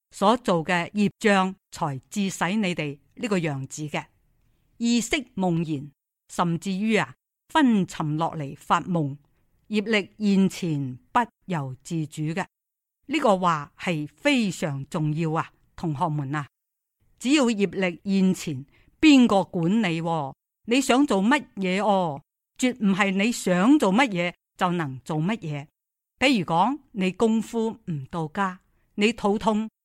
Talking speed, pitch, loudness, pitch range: 190 characters per minute, 185 Hz, -24 LUFS, 160-215 Hz